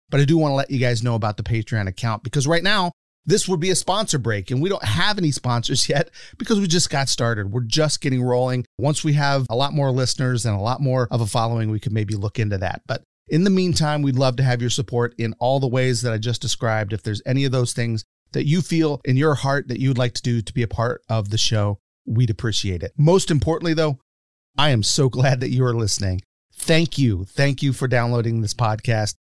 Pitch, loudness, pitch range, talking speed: 125 Hz, -21 LUFS, 115-145 Hz, 250 wpm